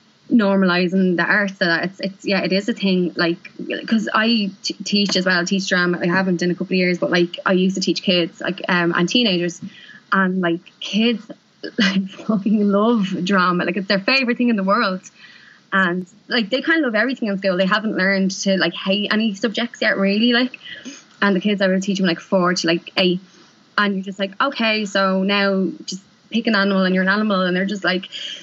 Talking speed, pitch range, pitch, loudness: 225 wpm, 185-215 Hz, 195 Hz, -19 LUFS